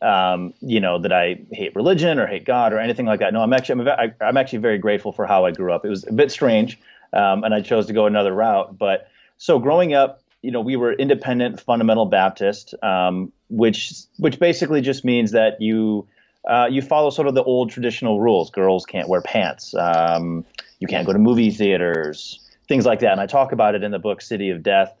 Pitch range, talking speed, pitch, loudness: 95-125 Hz, 225 wpm, 110 Hz, -19 LUFS